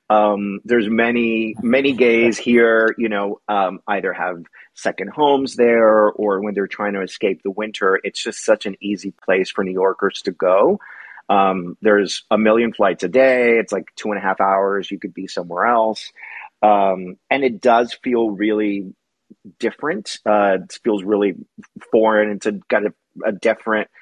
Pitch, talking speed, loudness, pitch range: 105 Hz, 175 wpm, -18 LUFS, 100-115 Hz